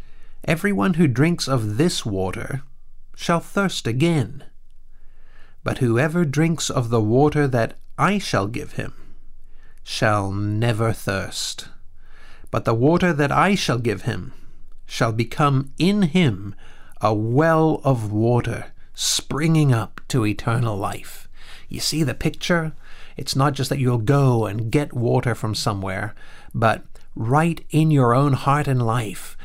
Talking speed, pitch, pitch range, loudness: 135 wpm, 130 Hz, 110-155 Hz, -21 LUFS